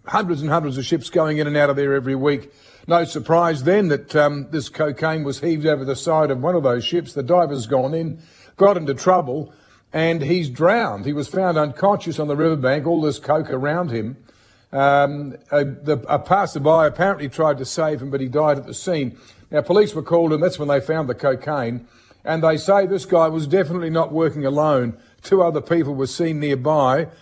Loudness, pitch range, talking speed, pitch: -20 LUFS, 140-165 Hz, 210 wpm, 150 Hz